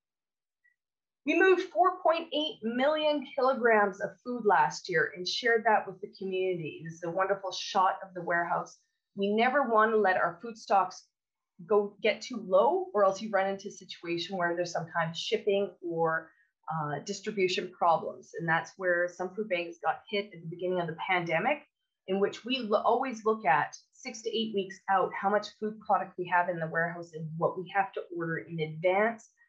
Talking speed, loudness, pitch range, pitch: 195 wpm, -30 LUFS, 175-225 Hz, 195 Hz